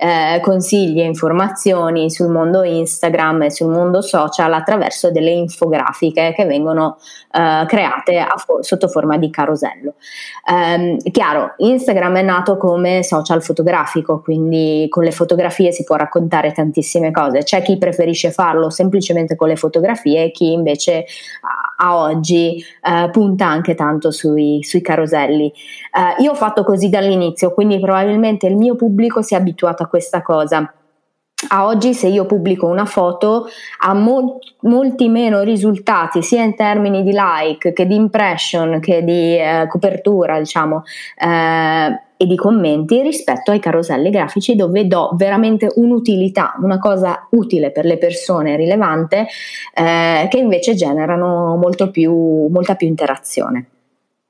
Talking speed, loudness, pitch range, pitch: 145 wpm, -14 LUFS, 160-200 Hz, 175 Hz